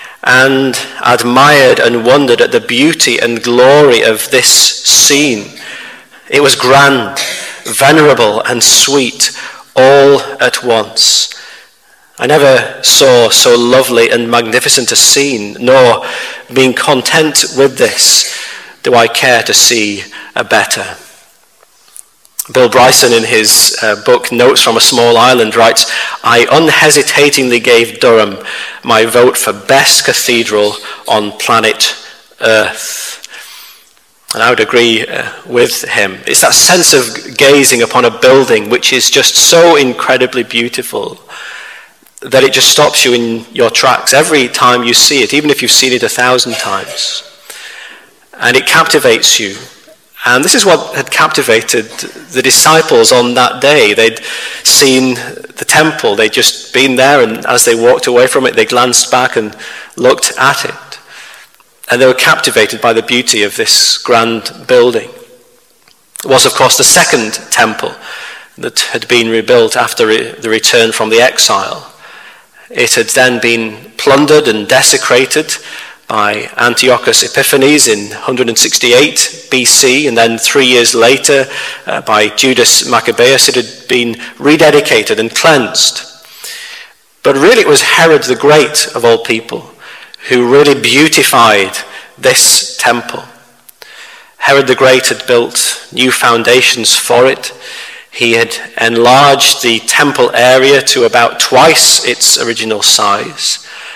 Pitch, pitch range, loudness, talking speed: 130 Hz, 120-170 Hz, -7 LUFS, 135 wpm